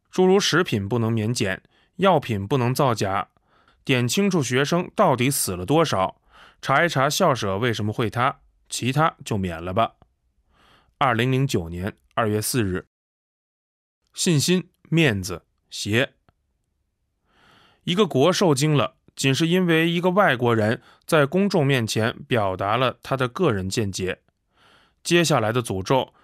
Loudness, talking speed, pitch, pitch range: -22 LUFS, 205 characters per minute, 130 Hz, 105-165 Hz